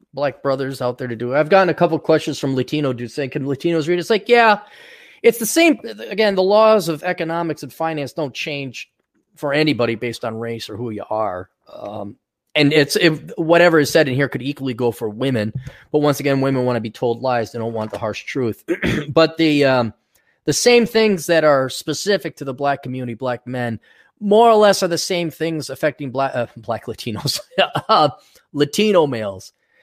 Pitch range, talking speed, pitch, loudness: 125-170 Hz, 205 wpm, 145 Hz, -18 LUFS